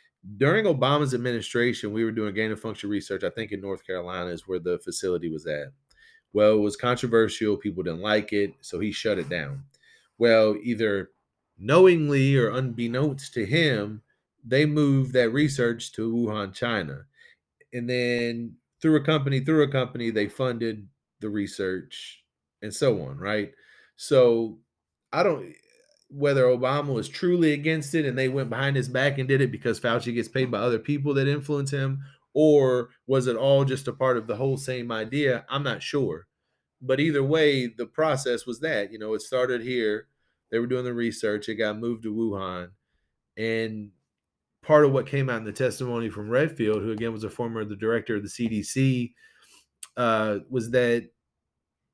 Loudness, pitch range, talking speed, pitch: -25 LUFS, 110-135 Hz, 175 wpm, 120 Hz